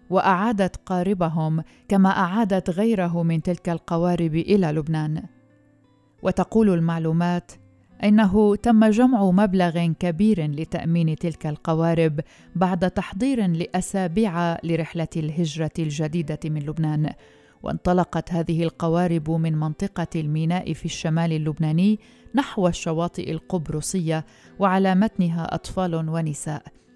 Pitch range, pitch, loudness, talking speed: 160-190 Hz, 170 Hz, -23 LUFS, 100 wpm